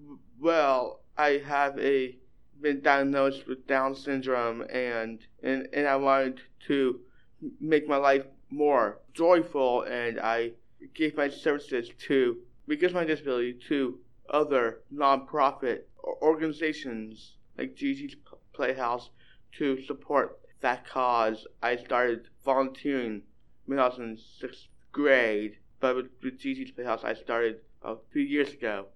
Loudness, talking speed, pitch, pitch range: -28 LUFS, 125 wpm, 135 Hz, 120-145 Hz